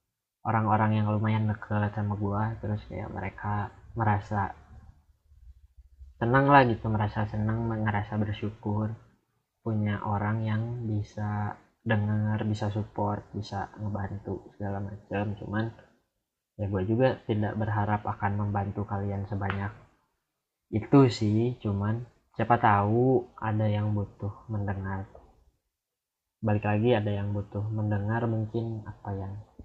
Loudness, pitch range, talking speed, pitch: -29 LUFS, 100-110 Hz, 115 wpm, 105 Hz